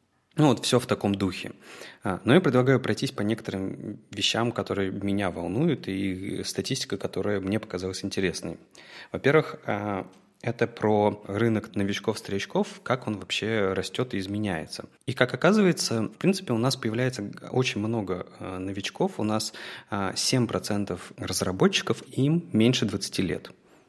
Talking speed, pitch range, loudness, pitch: 130 wpm, 100-125 Hz, -27 LUFS, 110 Hz